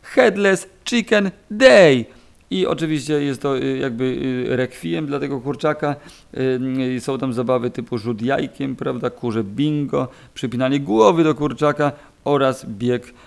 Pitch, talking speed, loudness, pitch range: 135 Hz, 120 wpm, -19 LUFS, 125-150 Hz